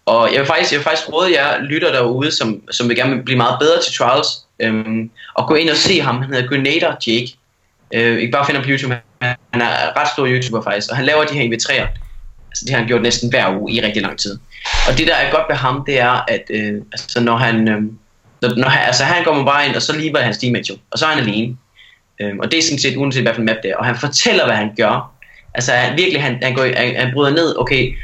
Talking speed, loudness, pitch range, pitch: 265 wpm, -15 LUFS, 115-140 Hz, 125 Hz